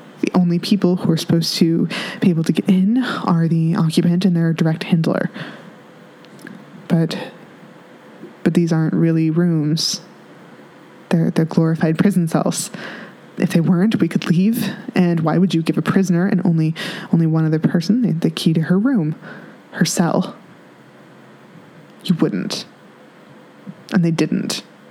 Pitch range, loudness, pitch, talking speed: 165-195 Hz, -18 LUFS, 175 Hz, 145 wpm